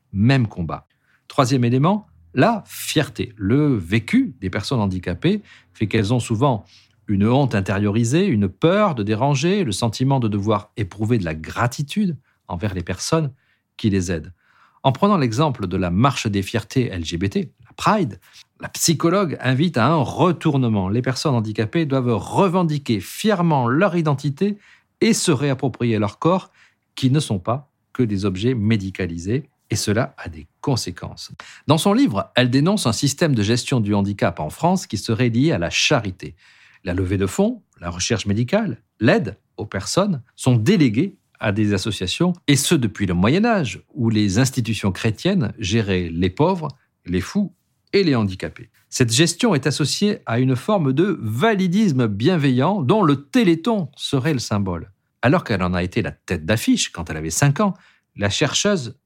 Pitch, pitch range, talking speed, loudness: 120 Hz, 105-155 Hz, 165 wpm, -20 LUFS